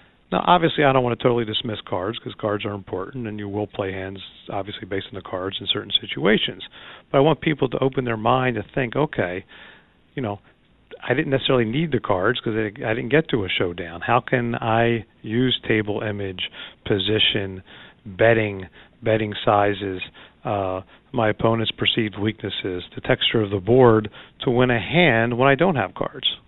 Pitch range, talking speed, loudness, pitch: 100-125 Hz, 185 wpm, -22 LUFS, 110 Hz